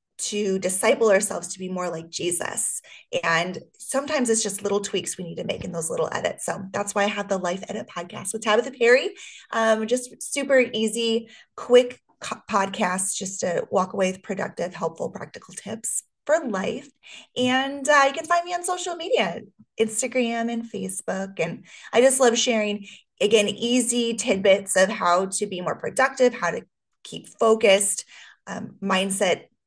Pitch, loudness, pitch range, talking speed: 220 Hz, -23 LUFS, 195-250 Hz, 170 wpm